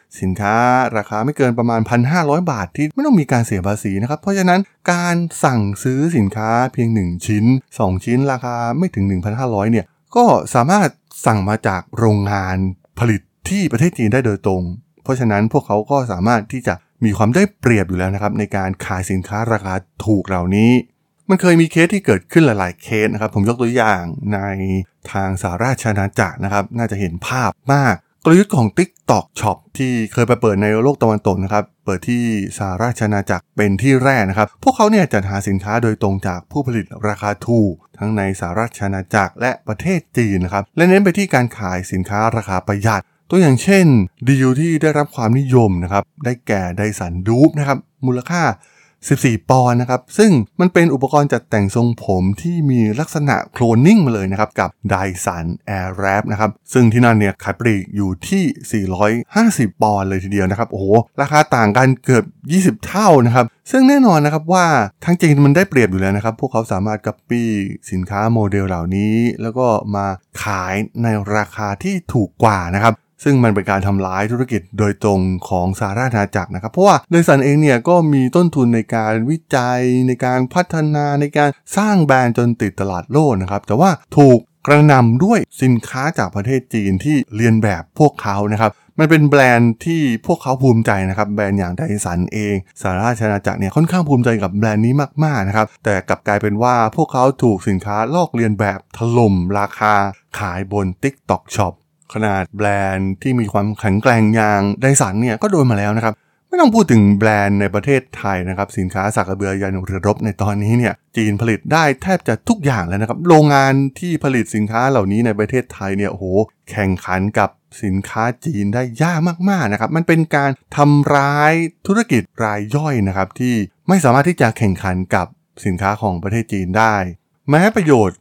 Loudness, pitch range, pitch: -16 LUFS, 100-140 Hz, 115 Hz